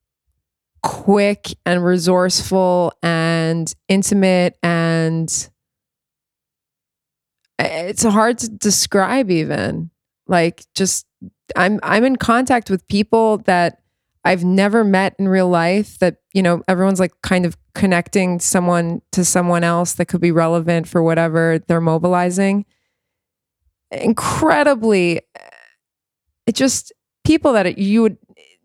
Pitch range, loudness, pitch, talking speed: 170-200 Hz, -16 LUFS, 180 Hz, 110 wpm